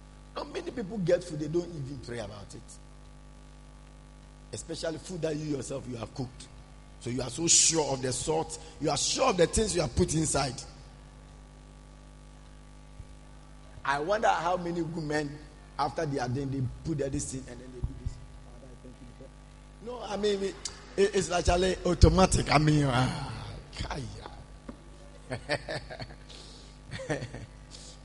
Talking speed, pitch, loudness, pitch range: 145 wpm, 145 Hz, -29 LUFS, 130-165 Hz